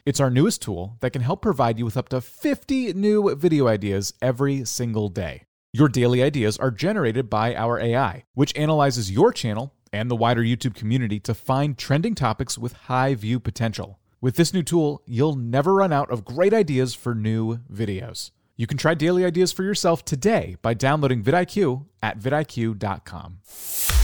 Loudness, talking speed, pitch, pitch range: -22 LUFS, 175 wpm, 125 Hz, 115-145 Hz